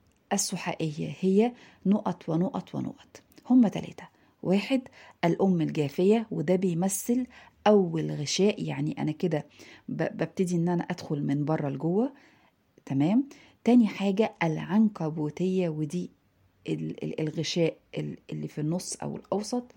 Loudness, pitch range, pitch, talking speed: -28 LUFS, 155-210 Hz, 180 Hz, 105 wpm